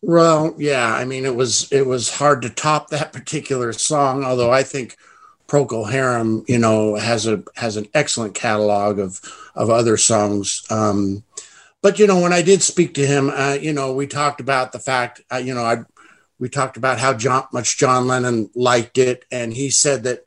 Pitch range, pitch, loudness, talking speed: 115-140 Hz, 130 Hz, -18 LUFS, 200 wpm